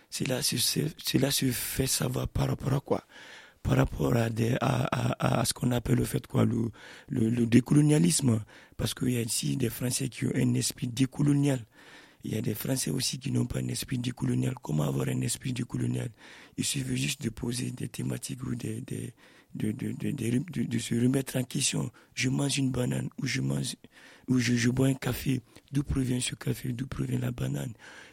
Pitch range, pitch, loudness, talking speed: 115-135 Hz, 125 Hz, -29 LUFS, 205 wpm